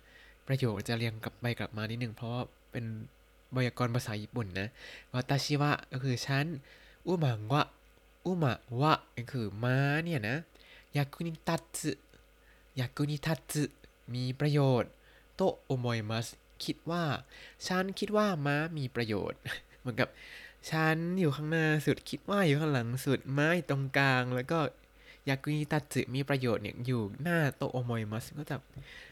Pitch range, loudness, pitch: 120-150 Hz, -33 LUFS, 135 Hz